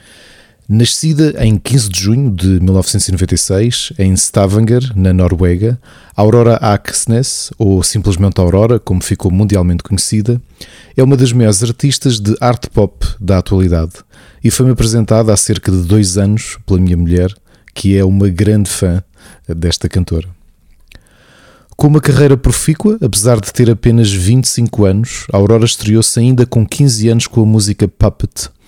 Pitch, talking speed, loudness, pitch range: 105 Hz, 140 wpm, -11 LUFS, 95-120 Hz